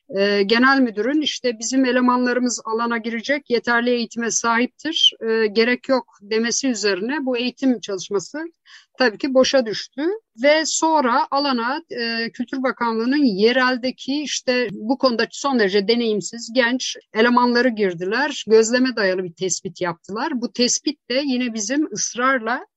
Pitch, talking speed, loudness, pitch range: 245 Hz, 125 wpm, -20 LUFS, 225-270 Hz